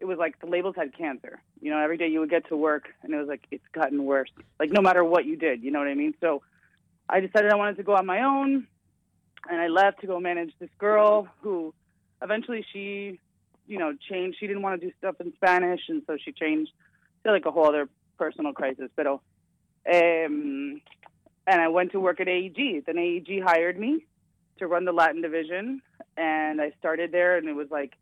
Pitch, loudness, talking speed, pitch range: 175 Hz, -26 LUFS, 220 wpm, 160-200 Hz